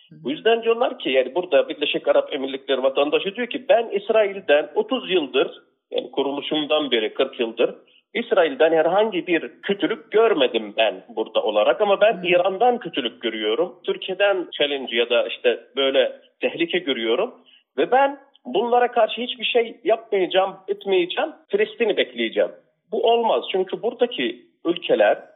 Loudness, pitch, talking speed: -21 LUFS, 225 Hz, 135 wpm